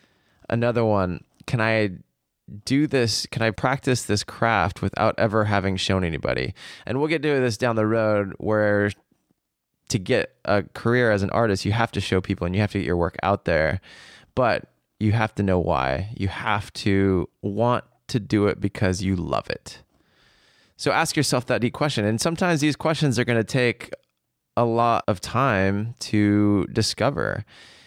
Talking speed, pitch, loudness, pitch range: 180 wpm, 110 Hz, -23 LUFS, 100-120 Hz